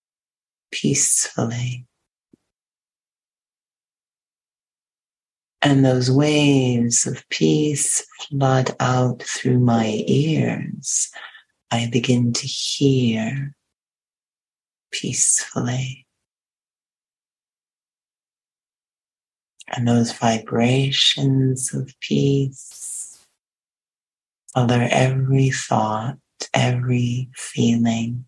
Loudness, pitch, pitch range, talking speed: -19 LUFS, 125 Hz, 115-135 Hz, 55 wpm